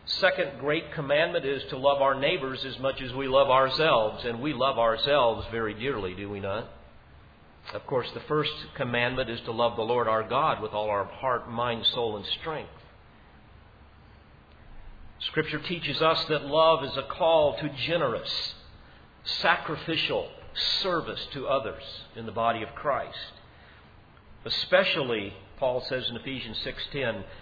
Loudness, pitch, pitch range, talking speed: -27 LUFS, 135 Hz, 115-150 Hz, 150 wpm